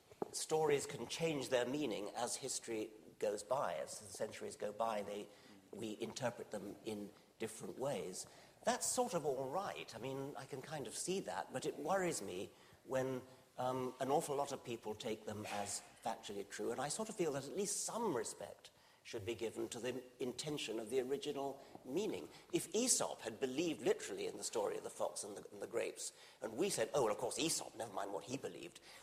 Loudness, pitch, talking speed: -42 LUFS, 140 Hz, 205 wpm